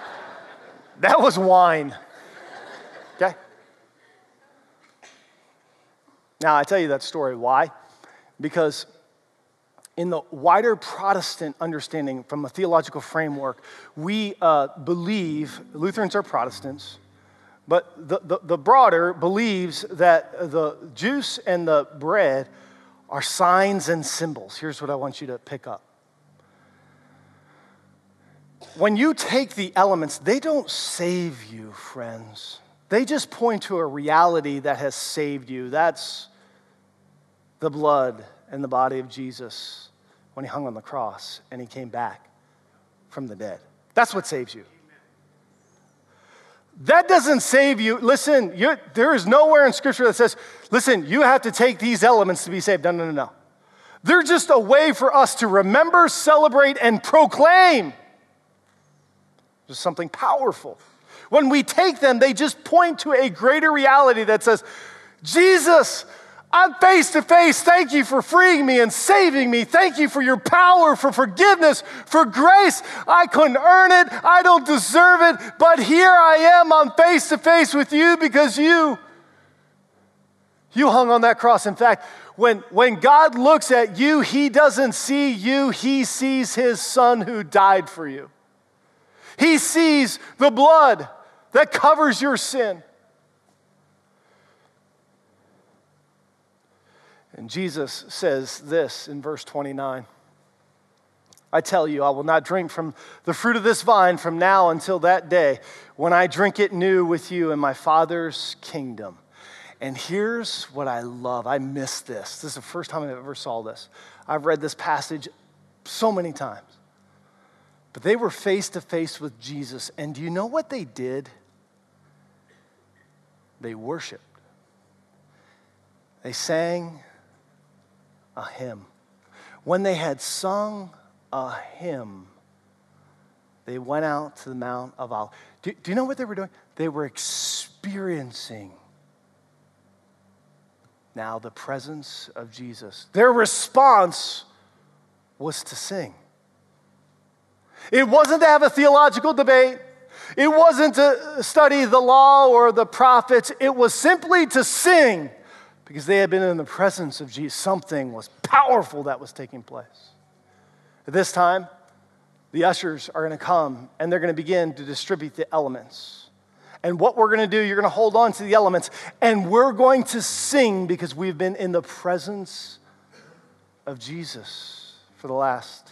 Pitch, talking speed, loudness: 190 Hz, 145 wpm, -18 LUFS